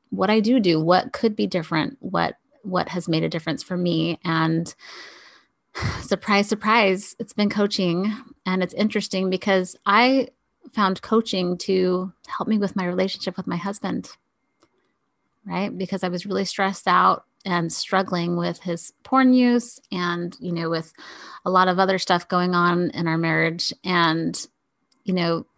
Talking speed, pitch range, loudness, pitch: 160 wpm, 175-210 Hz, -22 LUFS, 185 Hz